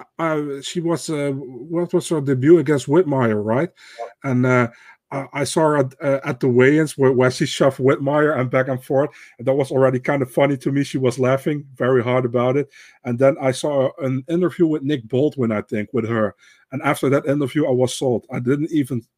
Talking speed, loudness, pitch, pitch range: 220 wpm, -19 LUFS, 135 Hz, 125-150 Hz